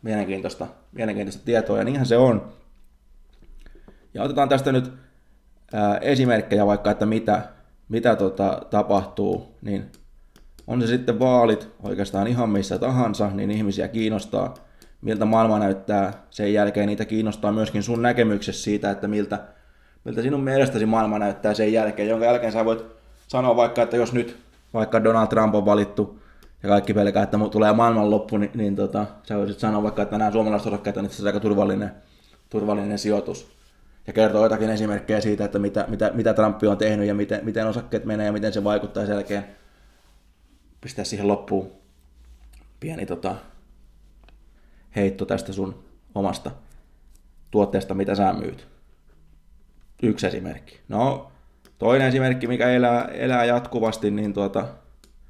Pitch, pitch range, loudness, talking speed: 105 Hz, 100-110 Hz, -22 LUFS, 150 wpm